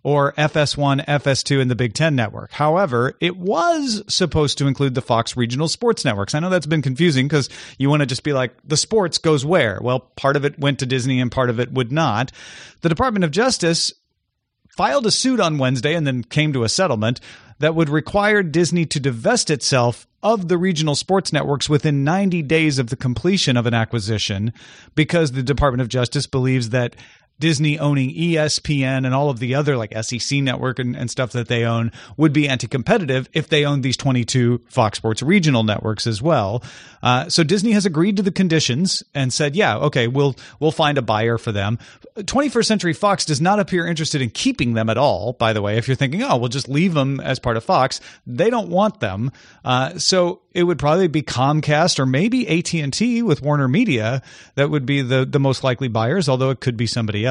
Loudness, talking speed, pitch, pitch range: -19 LUFS, 210 wpm, 140 Hz, 125-165 Hz